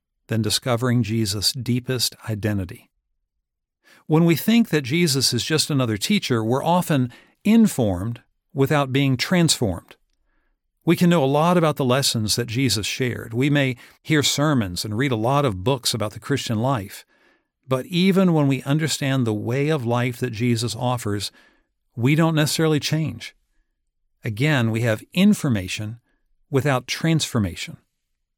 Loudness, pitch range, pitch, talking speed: -21 LUFS, 115-150 Hz, 130 Hz, 140 wpm